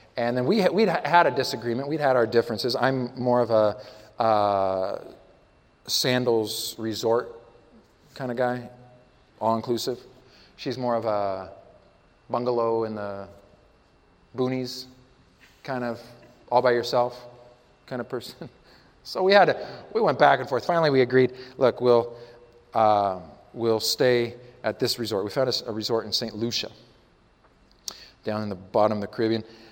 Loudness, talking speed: -24 LUFS, 150 wpm